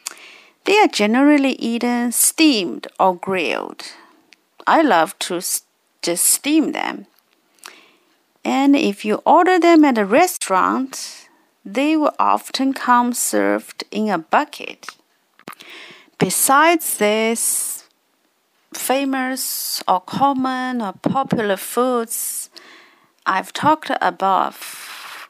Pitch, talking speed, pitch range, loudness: 265 Hz, 95 wpm, 225-315 Hz, -17 LUFS